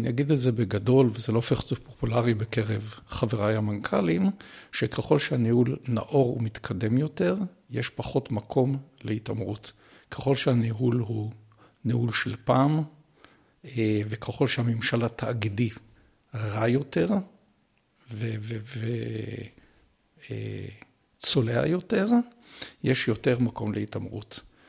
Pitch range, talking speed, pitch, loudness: 110-135 Hz, 95 wpm, 120 Hz, -27 LUFS